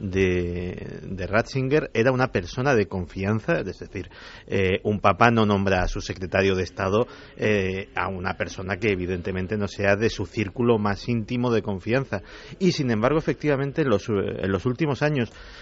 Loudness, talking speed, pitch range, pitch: -24 LUFS, 175 wpm, 95-120 Hz, 105 Hz